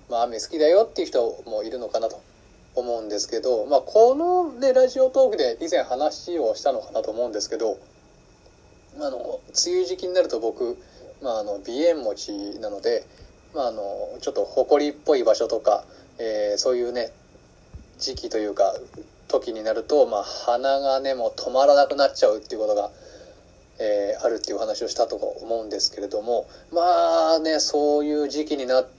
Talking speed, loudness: 300 characters per minute, -23 LUFS